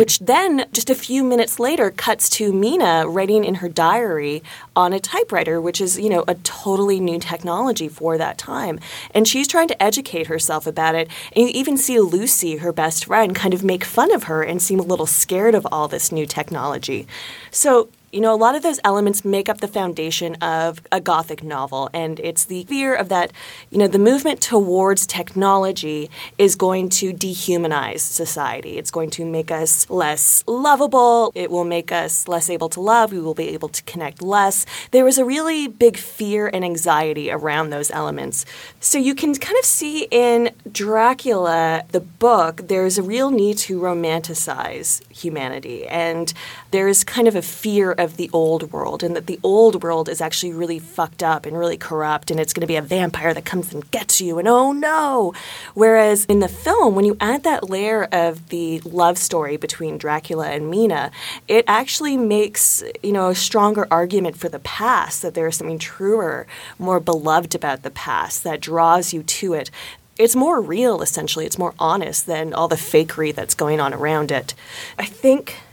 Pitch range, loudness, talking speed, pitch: 165-220 Hz, -18 LUFS, 195 wpm, 180 Hz